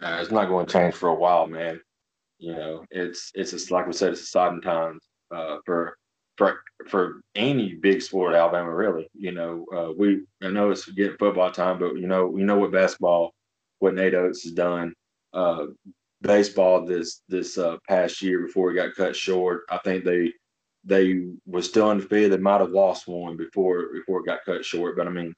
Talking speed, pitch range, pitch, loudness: 210 wpm, 85-95 Hz, 90 Hz, -24 LUFS